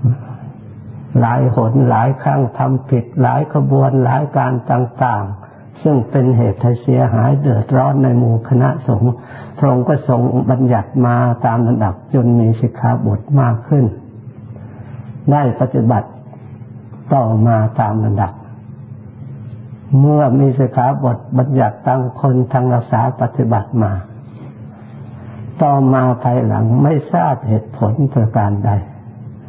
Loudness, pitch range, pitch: -14 LUFS, 115-130 Hz, 125 Hz